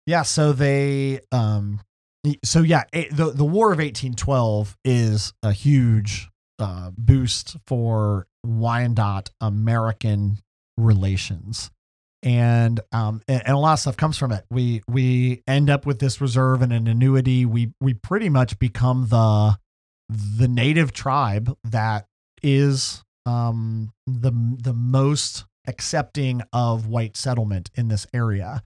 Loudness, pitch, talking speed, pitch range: -21 LUFS, 120 Hz, 130 wpm, 105-135 Hz